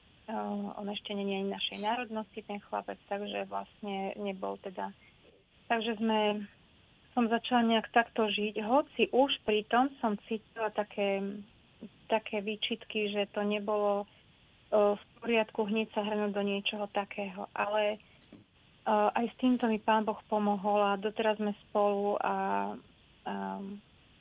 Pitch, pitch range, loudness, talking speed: 210 Hz, 200-220 Hz, -32 LUFS, 135 wpm